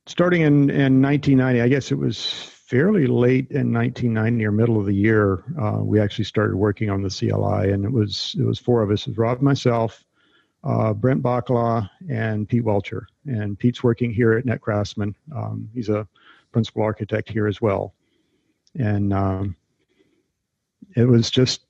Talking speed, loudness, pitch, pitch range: 175 wpm, -21 LUFS, 115 Hz, 105-125 Hz